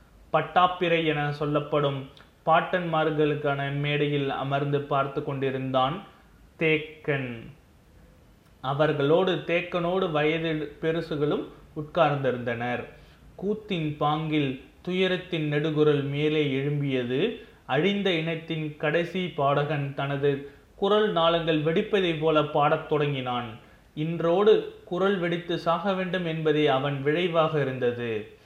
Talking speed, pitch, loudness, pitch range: 85 wpm, 150 Hz, -26 LUFS, 140-170 Hz